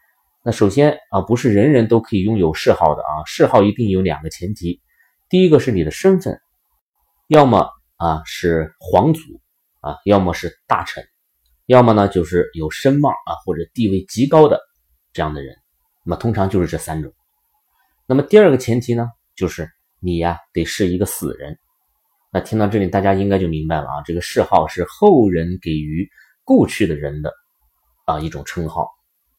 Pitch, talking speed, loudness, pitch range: 95 Hz, 260 characters per minute, -17 LUFS, 80-120 Hz